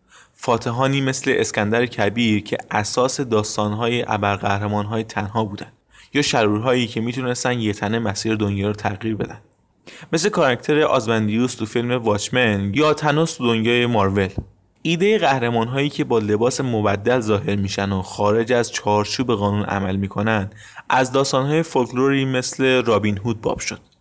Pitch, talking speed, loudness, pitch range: 115 Hz, 135 wpm, -20 LUFS, 105-130 Hz